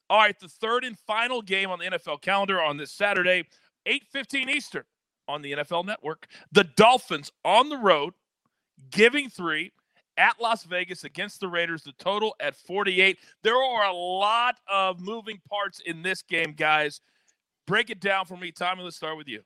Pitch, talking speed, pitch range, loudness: 190 Hz, 180 wpm, 170-215 Hz, -25 LUFS